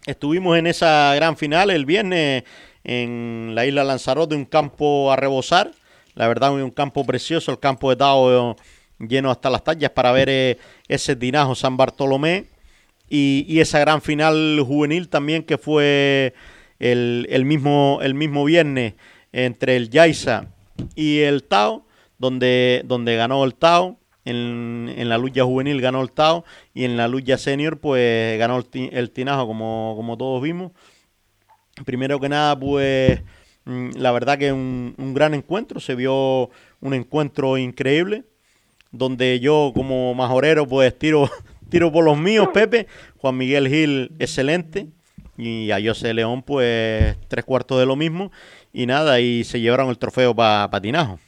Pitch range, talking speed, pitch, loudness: 125-150 Hz, 160 wpm, 135 Hz, -19 LUFS